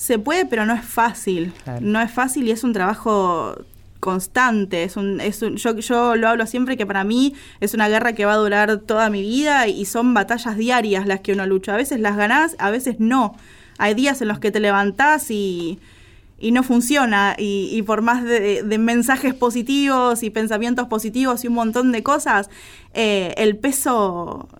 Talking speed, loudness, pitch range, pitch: 200 wpm, -19 LUFS, 200-245 Hz, 220 Hz